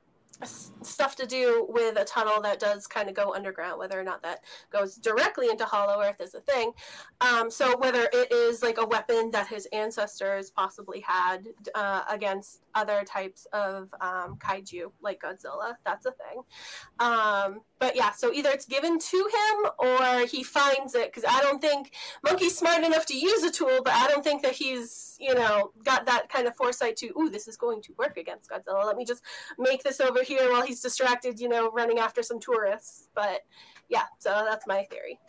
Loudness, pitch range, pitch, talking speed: -27 LUFS, 210-295 Hz, 245 Hz, 195 wpm